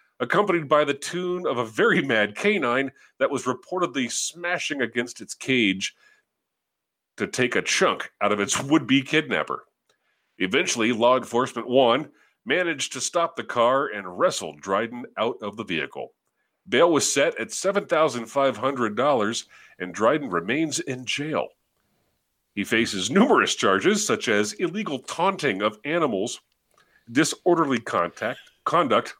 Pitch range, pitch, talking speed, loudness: 120-180 Hz, 140 Hz, 140 wpm, -23 LUFS